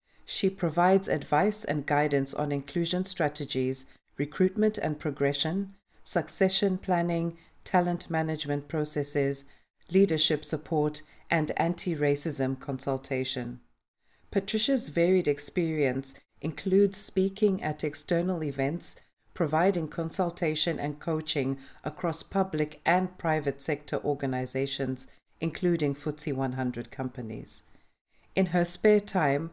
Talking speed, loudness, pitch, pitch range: 100 wpm, -28 LUFS, 155 Hz, 140-180 Hz